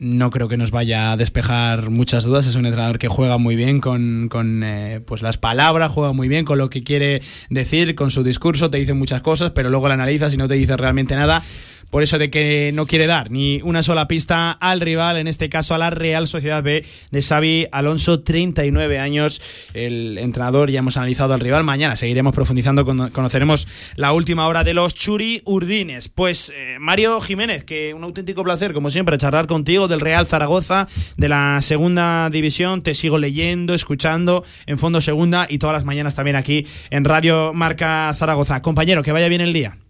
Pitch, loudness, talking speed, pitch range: 150 Hz, -17 LUFS, 200 wpm, 130-165 Hz